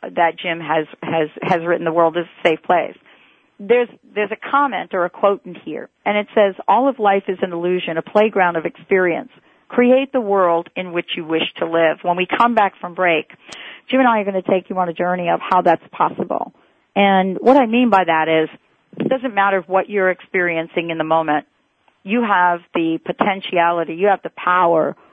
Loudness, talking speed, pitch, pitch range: -18 LUFS, 210 wpm, 180 Hz, 170-205 Hz